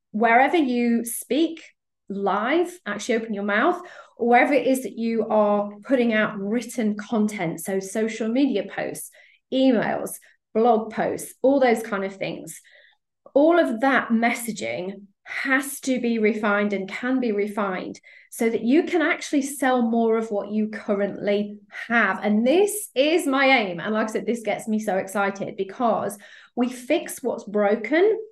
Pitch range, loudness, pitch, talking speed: 205-265 Hz, -23 LUFS, 230 Hz, 155 wpm